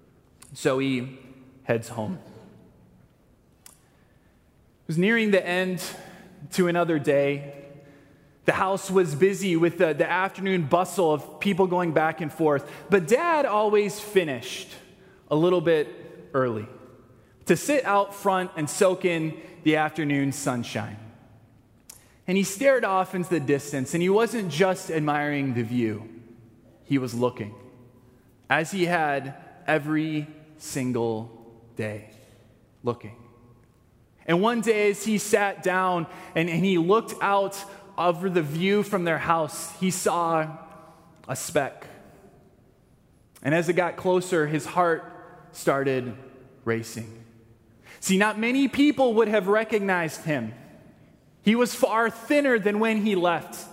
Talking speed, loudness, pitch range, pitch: 130 wpm, -25 LUFS, 130-190 Hz, 165 Hz